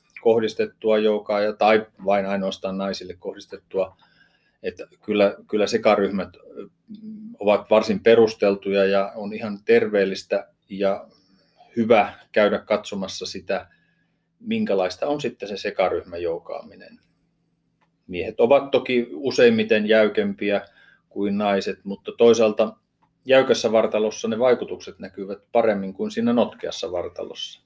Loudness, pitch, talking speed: -22 LUFS, 110 Hz, 105 wpm